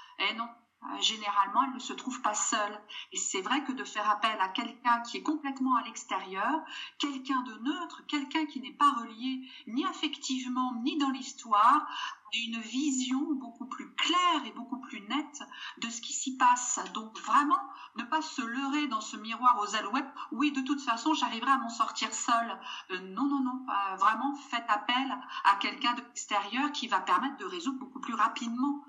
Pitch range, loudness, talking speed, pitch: 230-285 Hz, -31 LUFS, 190 wpm, 260 Hz